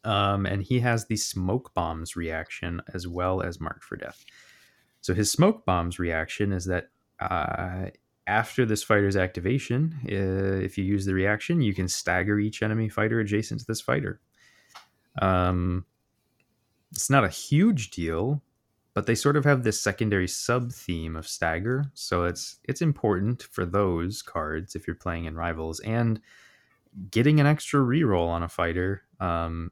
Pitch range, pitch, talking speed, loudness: 90-115 Hz, 100 Hz, 160 wpm, -27 LUFS